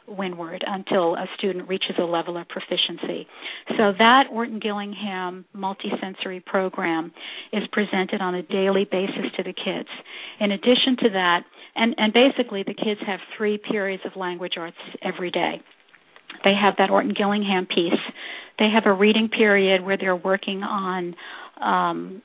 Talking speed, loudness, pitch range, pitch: 150 wpm, -22 LUFS, 185-215 Hz, 195 Hz